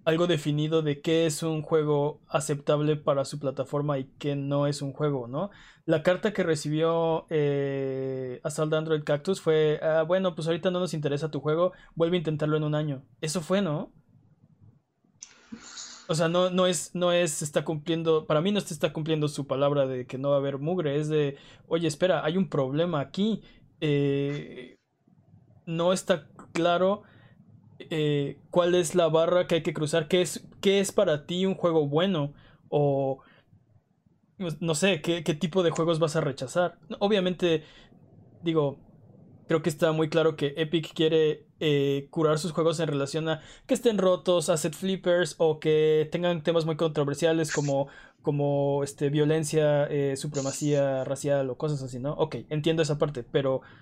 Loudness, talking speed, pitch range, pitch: -27 LUFS, 175 wpm, 145-170 Hz, 160 Hz